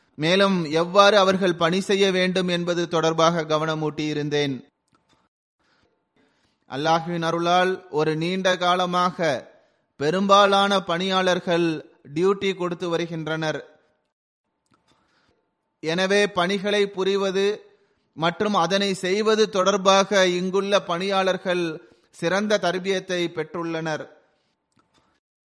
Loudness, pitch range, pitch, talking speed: -22 LUFS, 165-195 Hz, 180 Hz, 75 wpm